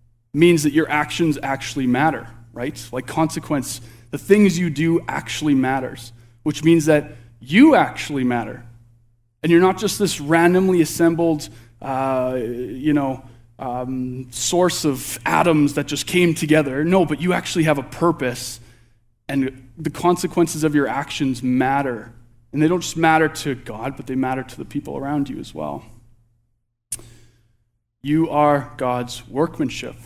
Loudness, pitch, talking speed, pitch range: -20 LUFS, 135 Hz, 150 wpm, 120-160 Hz